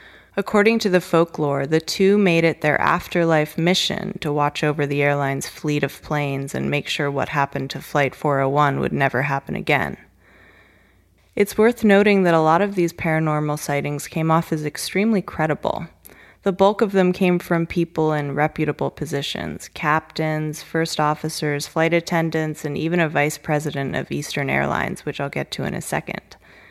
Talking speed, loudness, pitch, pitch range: 170 wpm, -21 LUFS, 155 Hz, 145-175 Hz